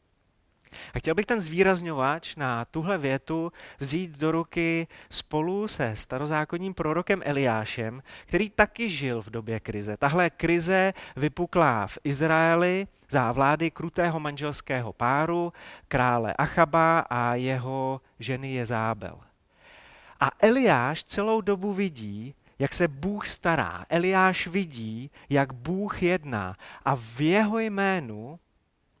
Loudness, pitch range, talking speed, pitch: -26 LUFS, 125-180 Hz, 115 wpm, 155 Hz